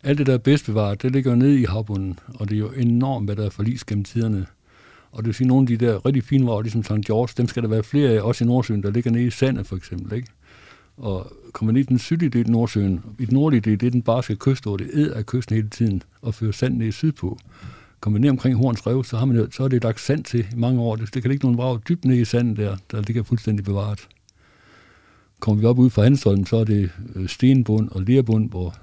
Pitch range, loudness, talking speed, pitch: 105-125 Hz, -21 LUFS, 275 wpm, 115 Hz